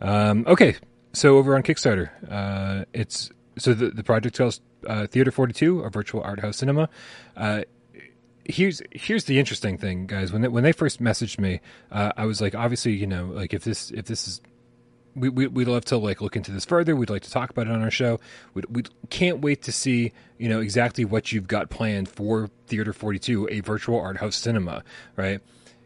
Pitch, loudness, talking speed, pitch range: 115 Hz, -24 LUFS, 205 wpm, 105-125 Hz